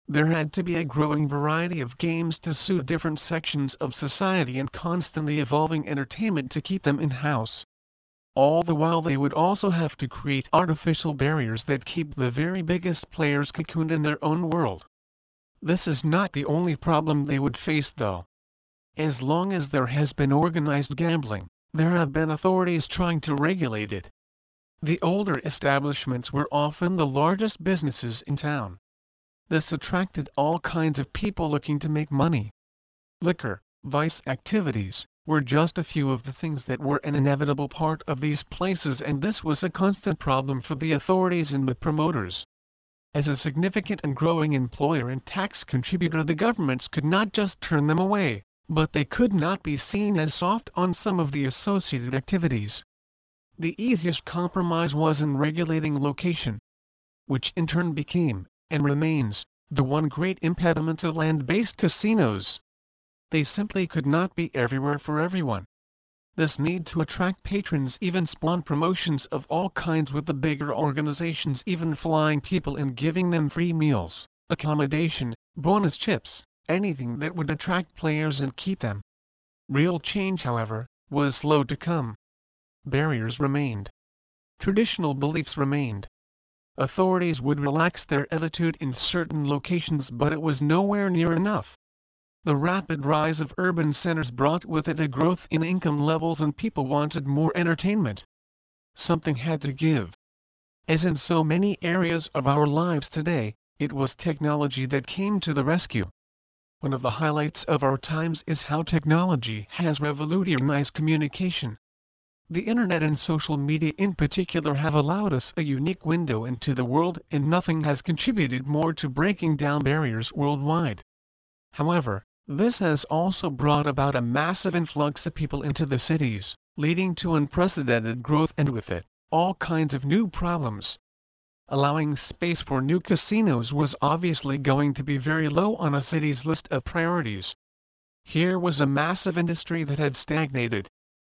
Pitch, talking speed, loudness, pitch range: 150 Hz, 160 wpm, -26 LUFS, 135-165 Hz